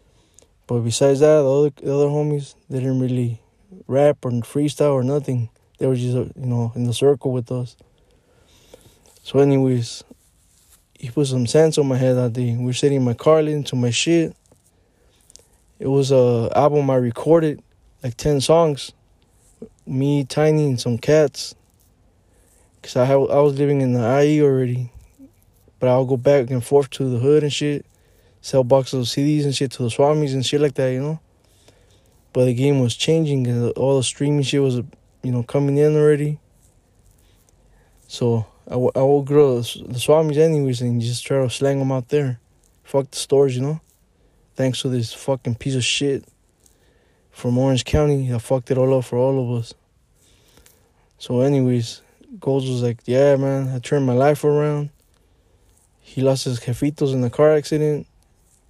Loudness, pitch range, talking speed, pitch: -19 LUFS, 120-145 Hz, 180 wpm, 130 Hz